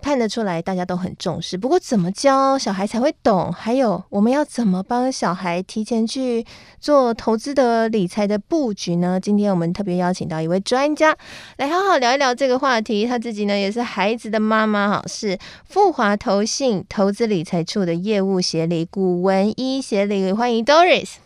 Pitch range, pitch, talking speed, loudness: 190-250 Hz, 215 Hz, 295 characters per minute, -19 LUFS